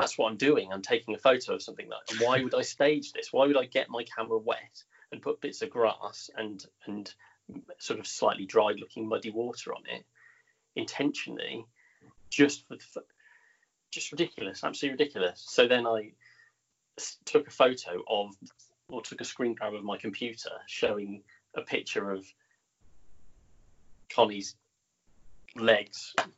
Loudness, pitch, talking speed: -30 LUFS, 125 Hz, 150 wpm